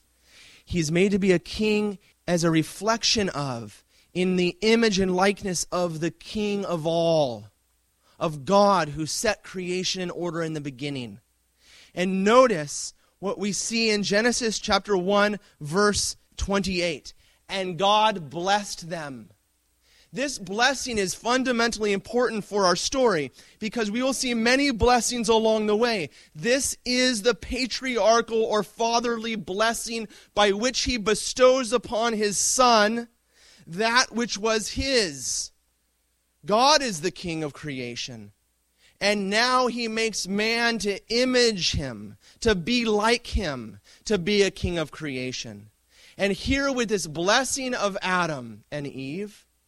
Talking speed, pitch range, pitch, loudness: 135 wpm, 155-230 Hz, 200 Hz, -24 LUFS